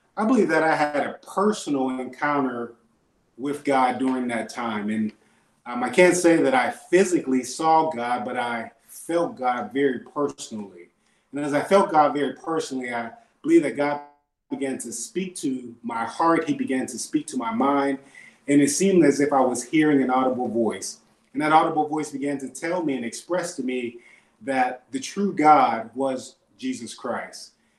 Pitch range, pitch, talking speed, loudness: 125-160 Hz, 140 Hz, 180 wpm, -23 LUFS